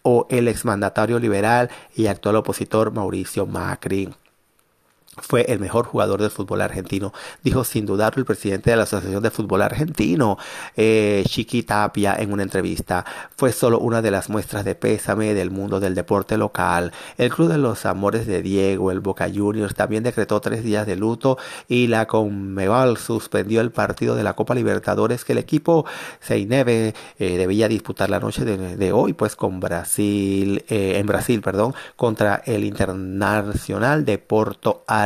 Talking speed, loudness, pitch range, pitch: 165 wpm, -21 LUFS, 100-115 Hz, 105 Hz